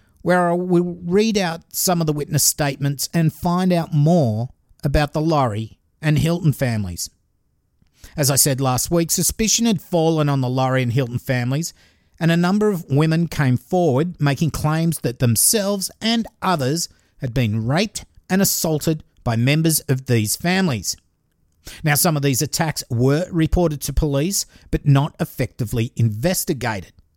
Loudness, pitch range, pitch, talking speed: -19 LUFS, 125-170 Hz, 150 Hz, 155 wpm